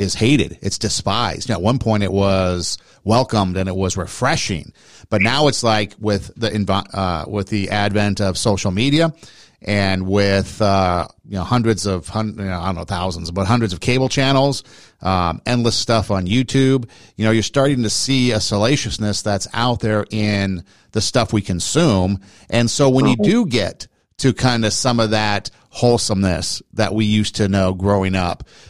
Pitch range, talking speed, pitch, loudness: 95-115 Hz, 190 wpm, 105 Hz, -18 LUFS